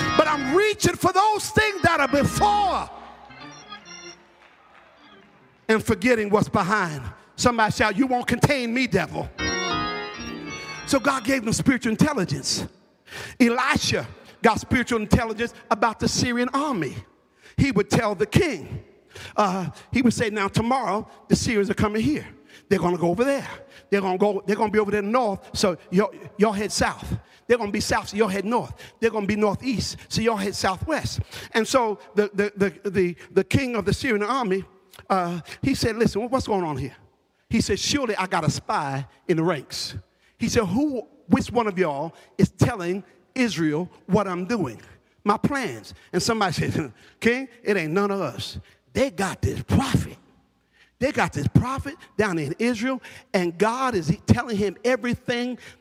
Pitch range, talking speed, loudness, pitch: 185-245 Hz, 170 wpm, -23 LUFS, 210 Hz